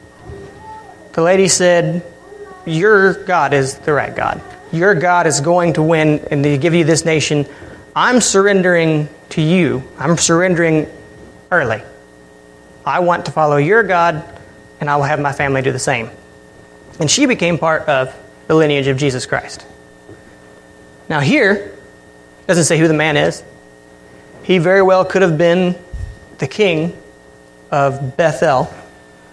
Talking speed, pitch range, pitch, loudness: 145 wpm, 130-175 Hz, 155 Hz, -14 LUFS